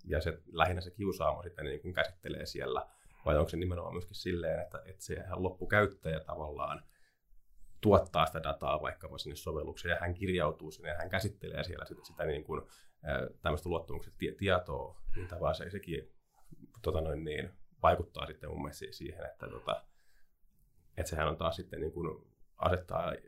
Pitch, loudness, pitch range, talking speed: 85 Hz, -36 LUFS, 80-90 Hz, 170 wpm